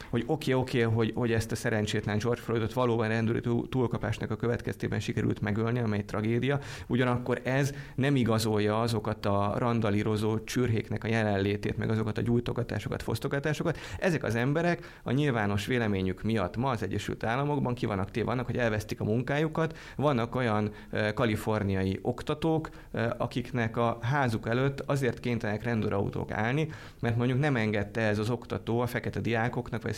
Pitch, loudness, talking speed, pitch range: 115 Hz, -30 LUFS, 155 wpm, 110-125 Hz